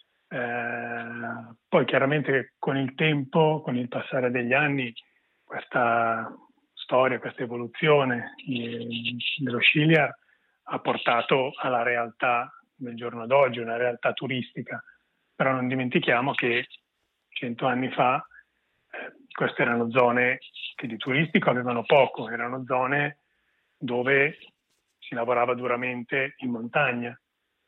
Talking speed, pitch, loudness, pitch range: 110 wpm, 125 Hz, -25 LUFS, 120-140 Hz